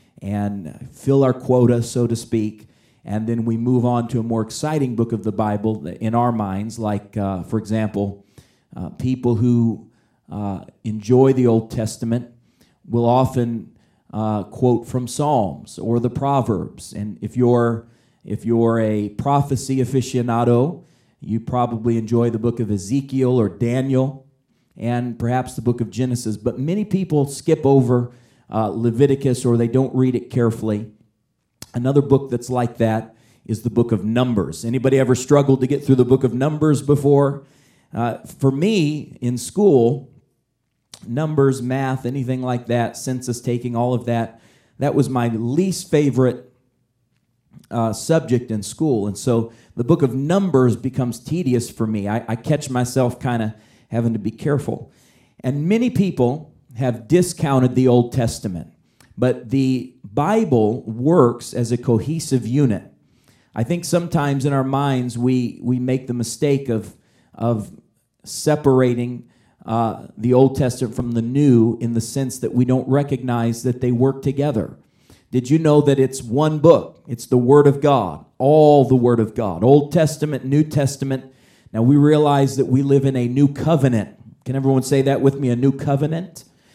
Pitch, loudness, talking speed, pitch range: 125 Hz, -19 LUFS, 160 wpm, 115-135 Hz